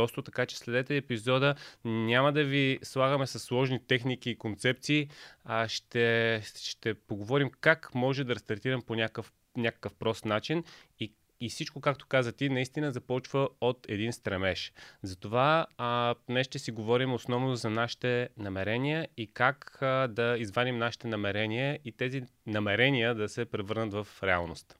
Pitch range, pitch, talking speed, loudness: 110-130 Hz, 120 Hz, 150 wpm, -31 LUFS